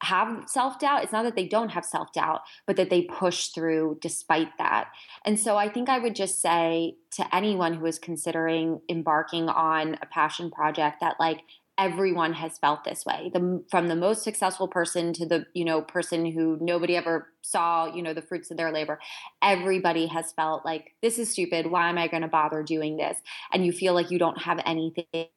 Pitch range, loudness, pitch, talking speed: 160-180 Hz, -27 LUFS, 170 Hz, 210 wpm